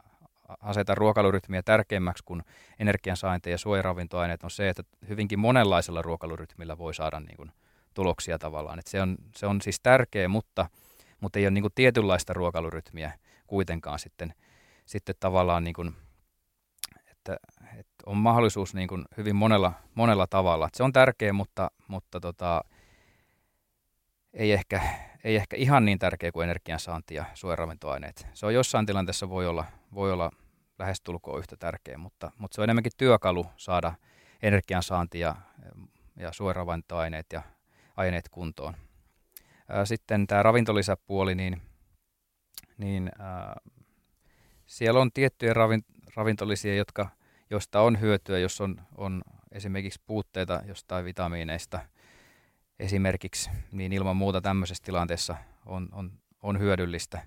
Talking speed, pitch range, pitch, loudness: 130 wpm, 85-105 Hz, 95 Hz, -28 LUFS